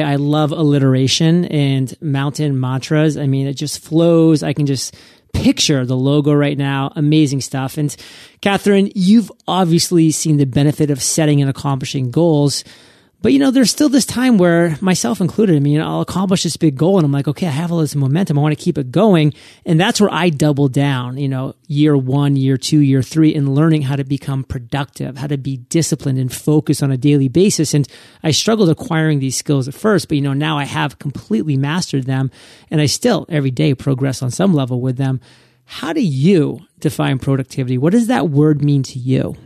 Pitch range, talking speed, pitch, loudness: 135-165 Hz, 210 wpm, 150 Hz, -15 LUFS